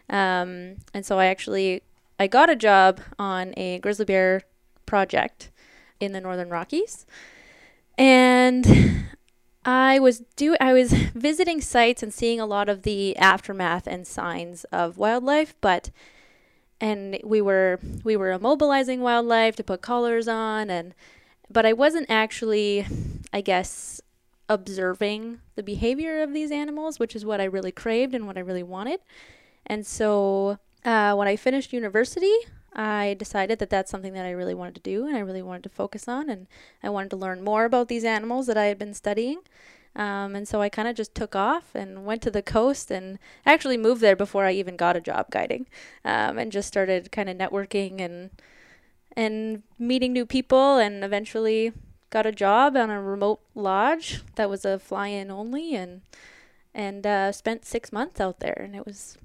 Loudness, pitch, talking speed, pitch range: -23 LUFS, 210 Hz, 175 wpm, 195-240 Hz